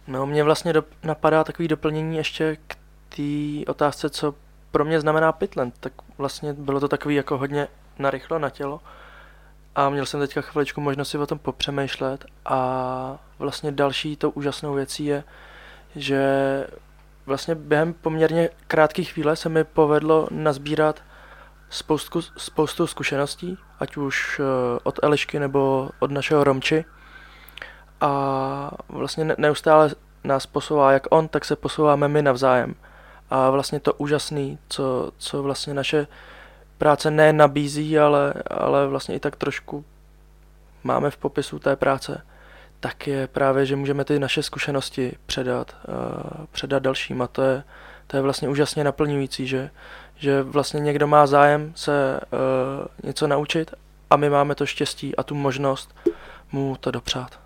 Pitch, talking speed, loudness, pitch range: 145 Hz, 145 wpm, -22 LUFS, 135-155 Hz